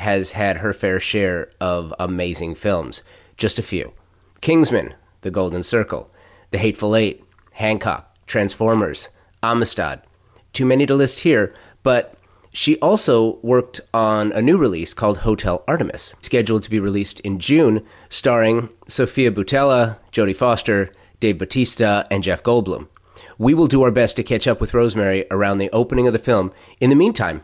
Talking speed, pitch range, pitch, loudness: 155 wpm, 95-120 Hz, 105 Hz, -18 LUFS